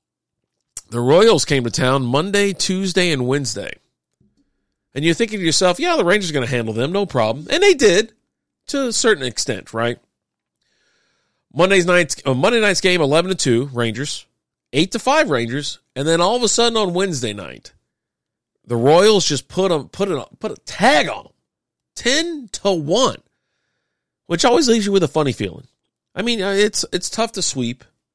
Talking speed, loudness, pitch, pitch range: 180 wpm, -17 LUFS, 165 Hz, 125-200 Hz